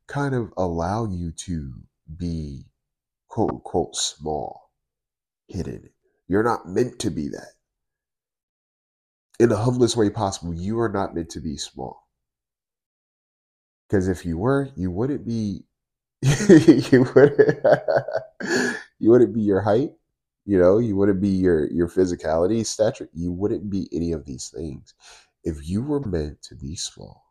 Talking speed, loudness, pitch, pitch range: 145 wpm, -22 LUFS, 95 Hz, 85-115 Hz